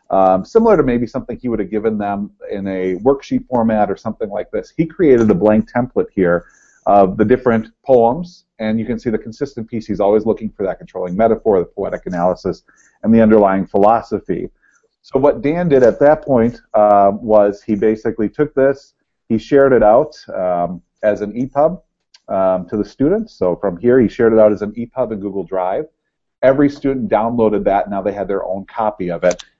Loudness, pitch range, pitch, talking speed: -16 LUFS, 100-135 Hz, 110 Hz, 205 wpm